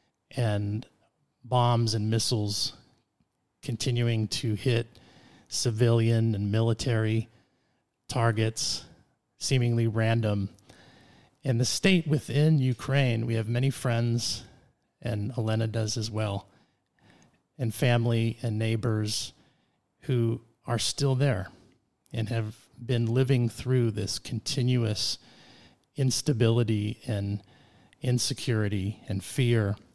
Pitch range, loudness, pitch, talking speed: 110-125 Hz, -28 LUFS, 115 Hz, 95 wpm